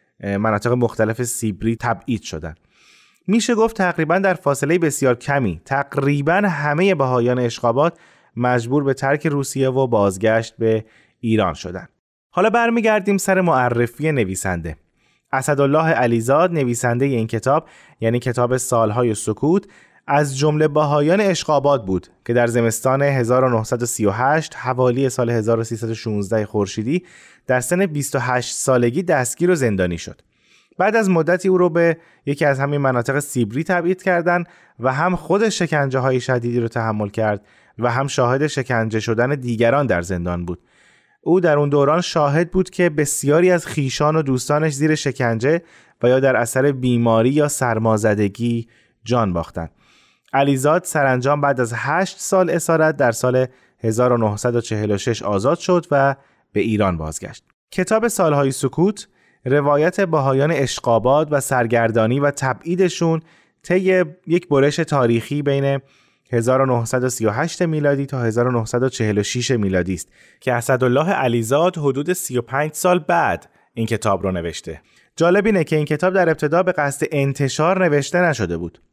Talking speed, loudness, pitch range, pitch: 135 wpm, -18 LUFS, 115-155 Hz, 135 Hz